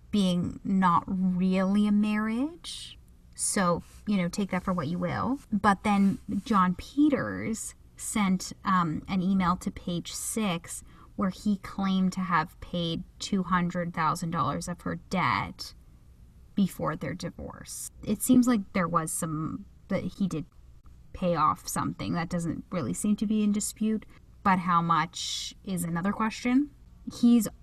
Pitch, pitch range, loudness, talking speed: 190 Hz, 175-210 Hz, -28 LUFS, 150 wpm